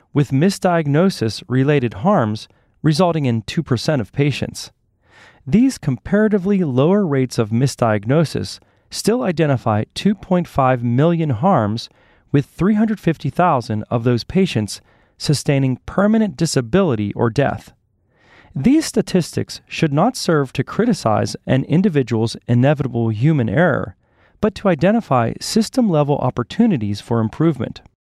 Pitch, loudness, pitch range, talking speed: 140 Hz, -18 LUFS, 115-180 Hz, 105 wpm